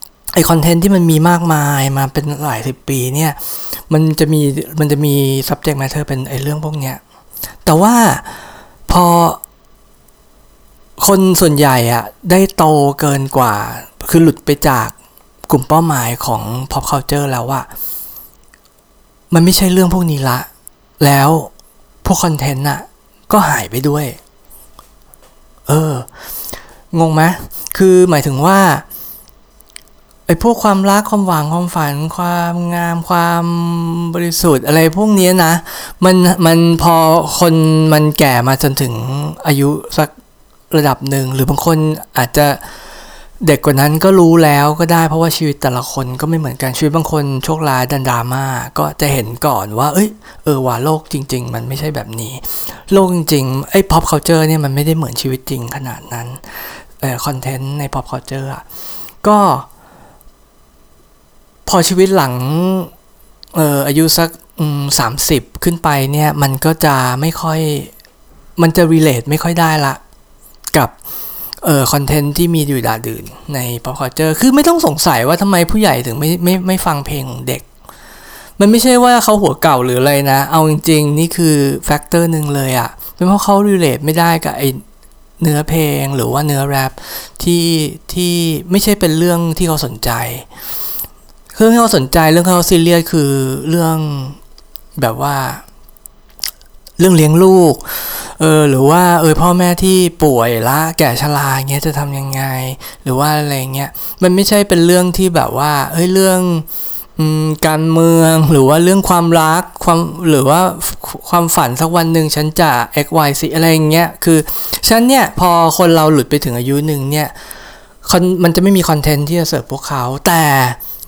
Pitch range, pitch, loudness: 140-170 Hz, 155 Hz, -12 LUFS